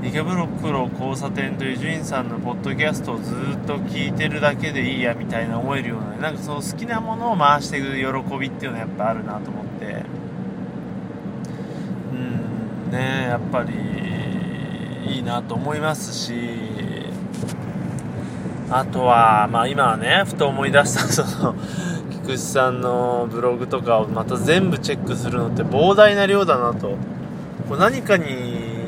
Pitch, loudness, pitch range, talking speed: 125 Hz, -21 LUFS, 110-150 Hz, 305 characters per minute